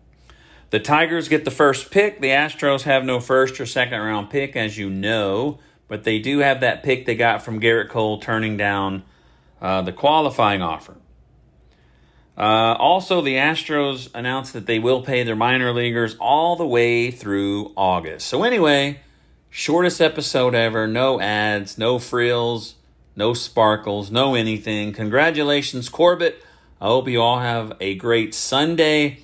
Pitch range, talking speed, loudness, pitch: 105-140 Hz, 155 wpm, -19 LUFS, 120 Hz